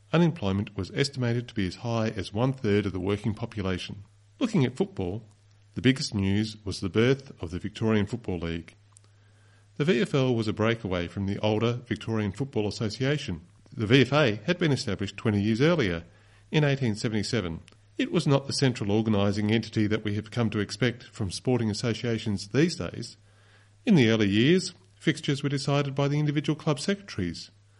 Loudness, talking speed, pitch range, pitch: -27 LUFS, 170 wpm, 100-130 Hz, 110 Hz